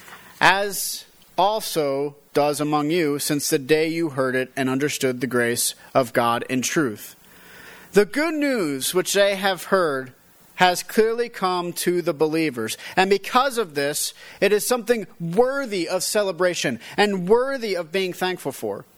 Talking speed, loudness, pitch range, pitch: 150 wpm, -22 LUFS, 145-205 Hz, 175 Hz